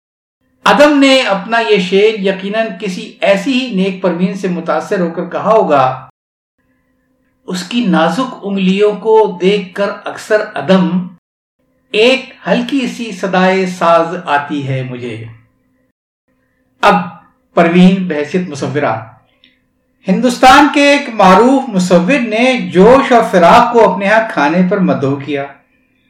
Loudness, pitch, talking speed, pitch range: -11 LUFS, 195 Hz, 125 wpm, 175-225 Hz